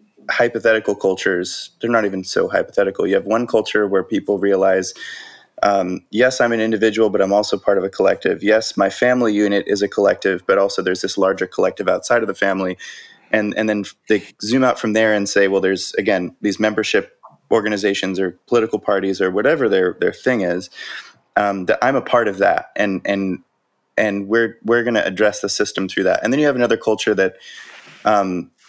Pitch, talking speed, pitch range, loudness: 105 Hz, 200 wpm, 100-110 Hz, -18 LUFS